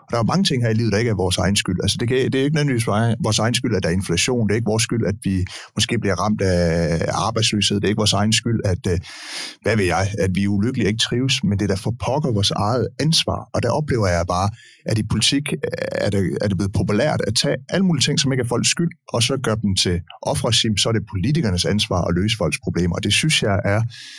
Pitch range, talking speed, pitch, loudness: 100-120 Hz, 270 wpm, 110 Hz, -19 LUFS